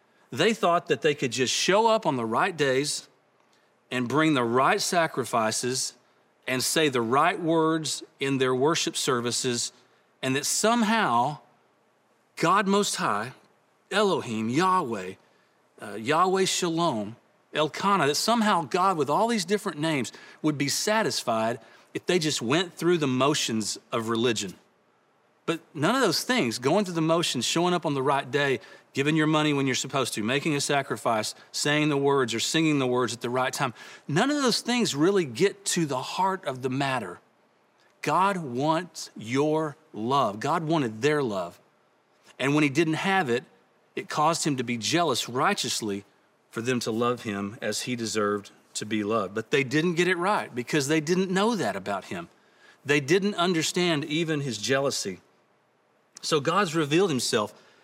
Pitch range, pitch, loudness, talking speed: 125-175 Hz, 145 Hz, -25 LUFS, 165 wpm